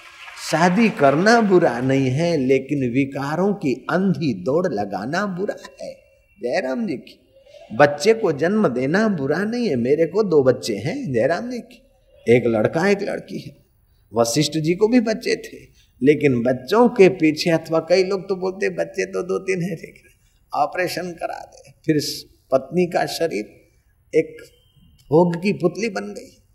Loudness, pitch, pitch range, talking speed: -20 LUFS, 170 Hz, 140-210 Hz, 160 wpm